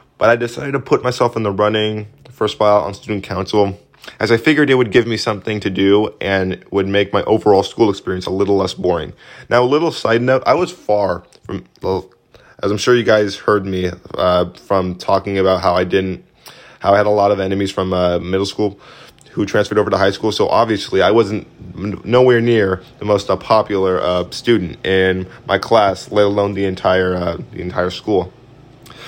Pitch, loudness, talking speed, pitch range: 100 Hz, -16 LUFS, 205 wpm, 95-110 Hz